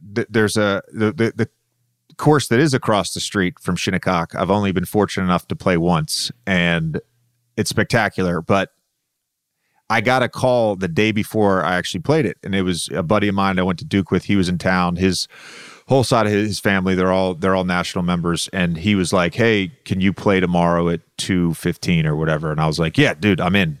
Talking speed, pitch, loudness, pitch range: 215 wpm, 95 Hz, -19 LUFS, 90-110 Hz